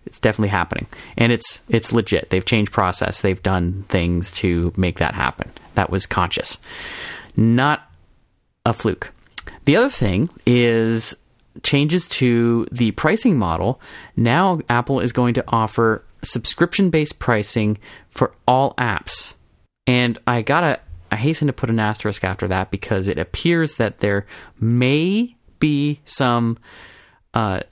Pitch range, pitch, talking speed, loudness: 100-135 Hz, 115 Hz, 140 wpm, -19 LUFS